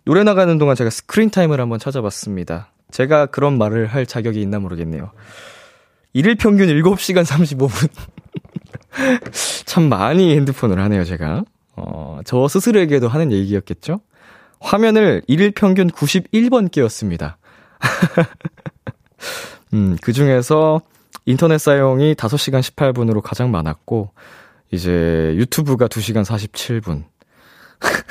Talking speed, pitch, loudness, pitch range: 250 characters per minute, 130 Hz, -16 LUFS, 105-165 Hz